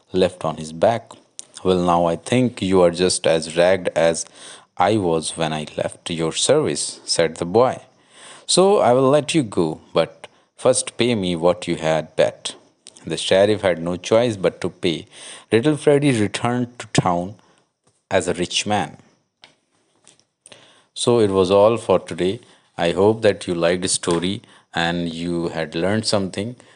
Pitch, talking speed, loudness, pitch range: 90 Hz, 165 wpm, -19 LUFS, 85-105 Hz